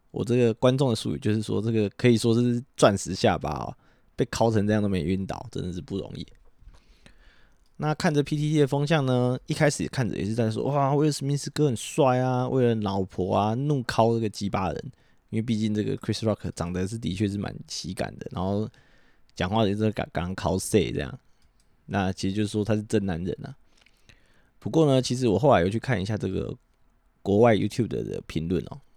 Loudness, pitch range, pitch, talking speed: -26 LUFS, 100-130 Hz, 110 Hz, 330 characters per minute